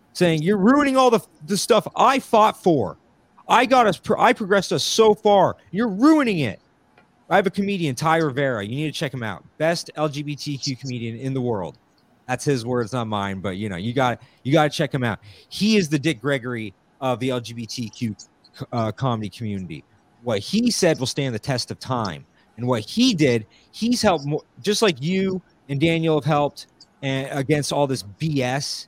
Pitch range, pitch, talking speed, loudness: 120-185 Hz, 145 Hz, 195 wpm, -21 LUFS